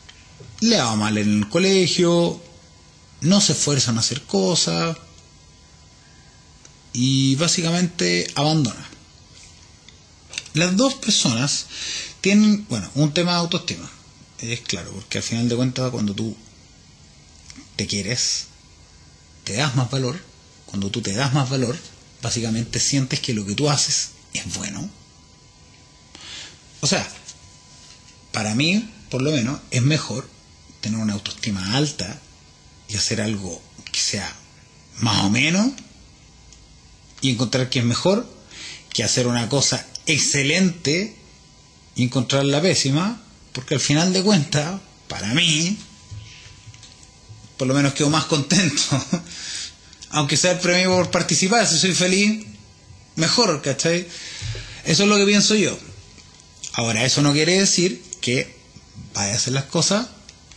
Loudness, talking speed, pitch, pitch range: -20 LUFS, 130 wpm, 125 Hz, 100-160 Hz